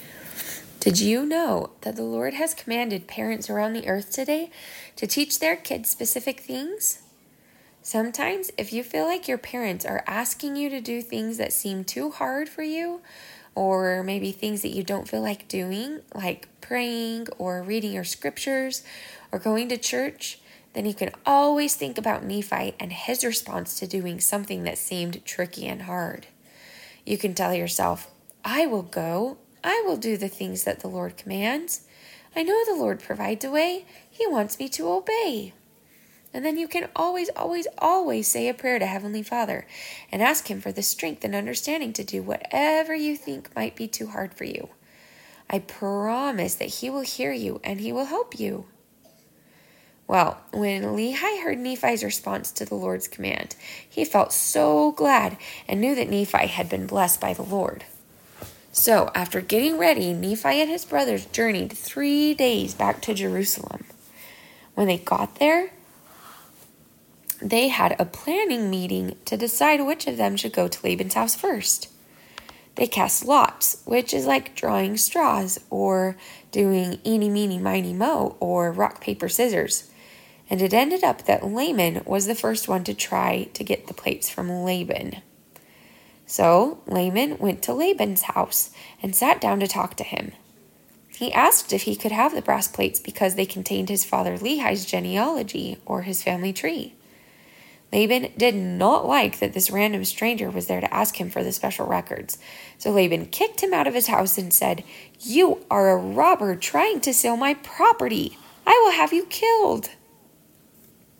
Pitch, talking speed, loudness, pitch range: 225 Hz, 170 wpm, -24 LUFS, 190-285 Hz